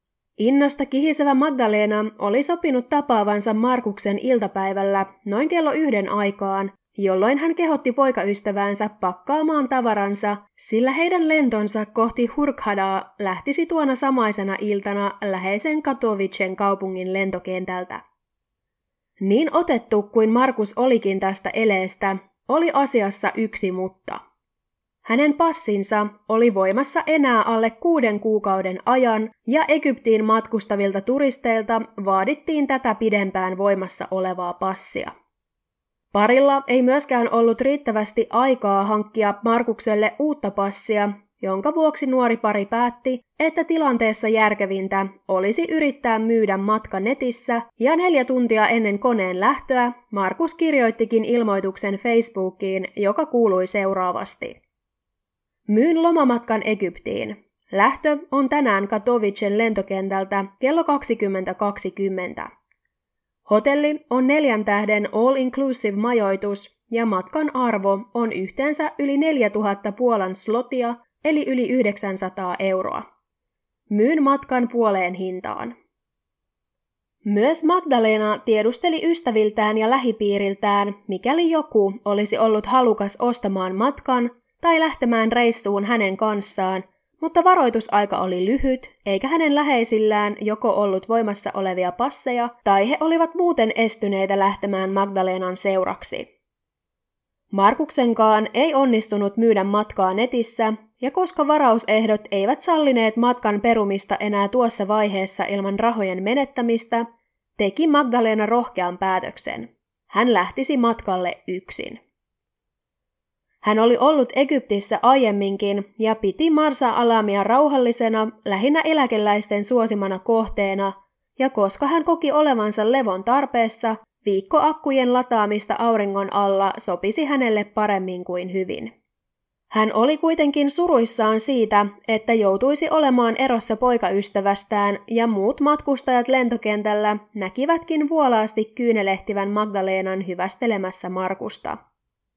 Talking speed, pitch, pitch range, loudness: 105 wpm, 220 Hz, 200-260 Hz, -20 LUFS